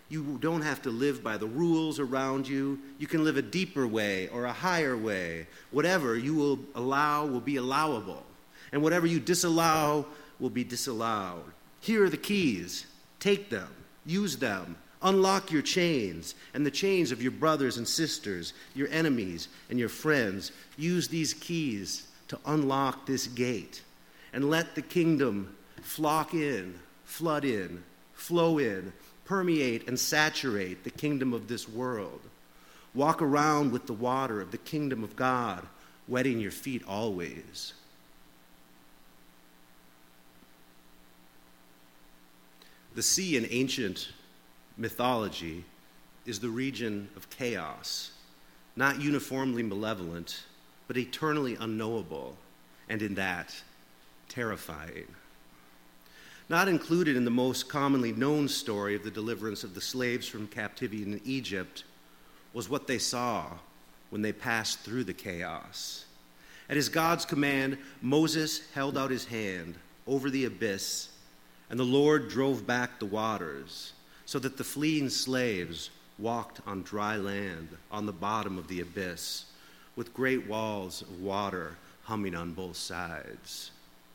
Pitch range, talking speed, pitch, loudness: 85-140 Hz, 135 wpm, 115 Hz, -31 LUFS